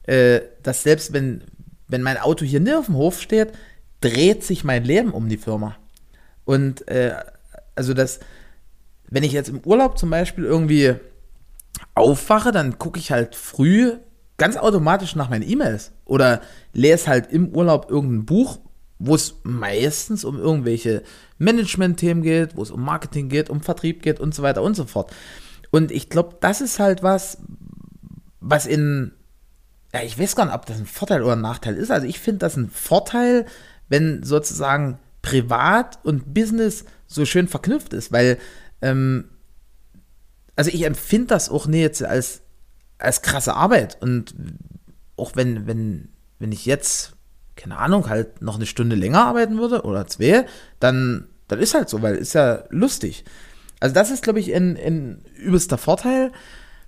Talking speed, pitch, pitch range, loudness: 165 wpm, 150 Hz, 125-180 Hz, -20 LUFS